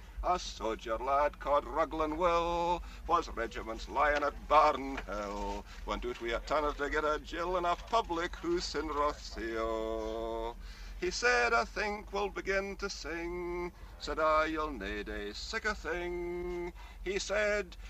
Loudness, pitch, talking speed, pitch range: -34 LUFS, 155 Hz, 150 wpm, 115-180 Hz